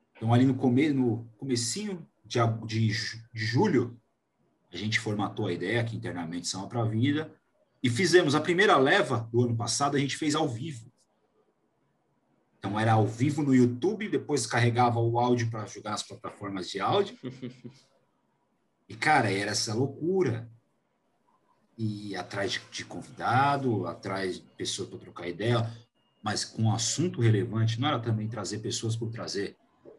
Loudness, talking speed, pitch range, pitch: -28 LUFS, 155 wpm, 110-130 Hz, 120 Hz